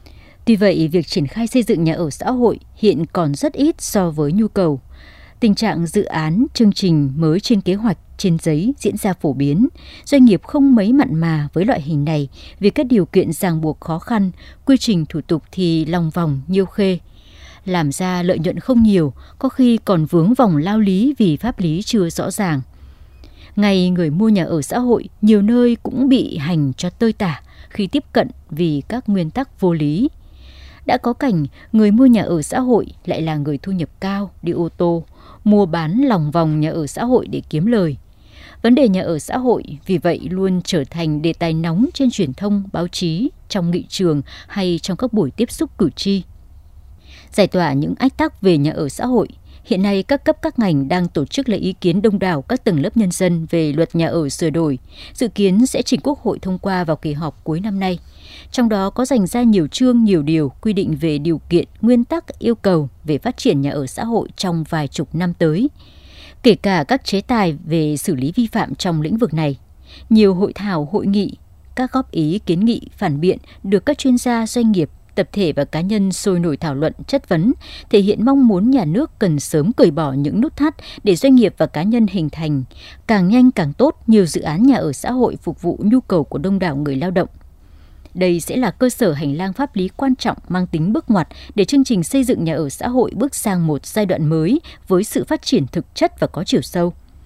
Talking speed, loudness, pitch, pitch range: 225 wpm, -17 LUFS, 185 Hz, 160-230 Hz